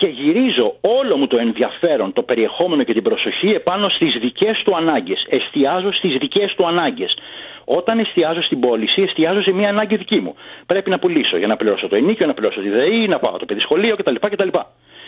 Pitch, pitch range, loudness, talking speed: 195 Hz, 140-230 Hz, -17 LUFS, 195 wpm